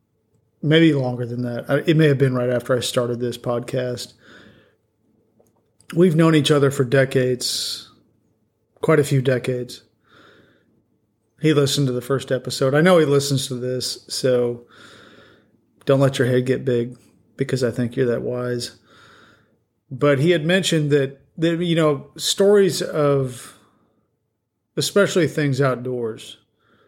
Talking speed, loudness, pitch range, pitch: 140 wpm, -20 LUFS, 120-145 Hz, 130 Hz